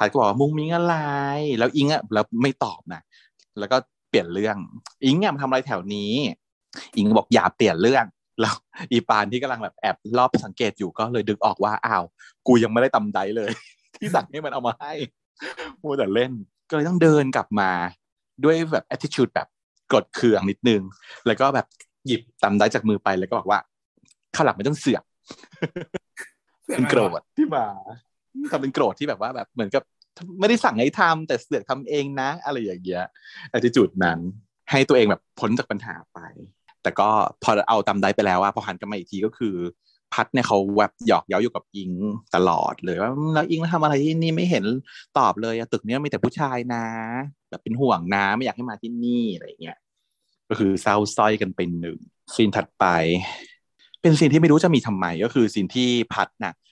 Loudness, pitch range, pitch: -22 LUFS, 105-150 Hz, 125 Hz